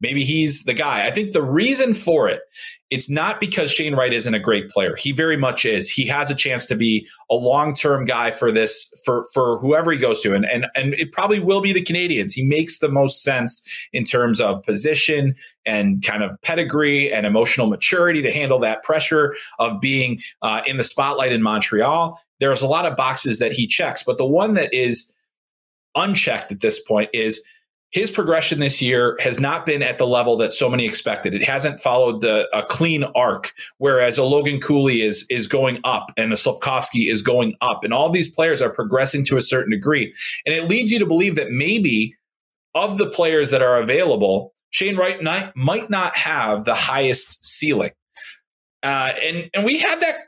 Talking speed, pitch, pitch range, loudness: 200 wpm, 145 Hz, 125-175 Hz, -18 LUFS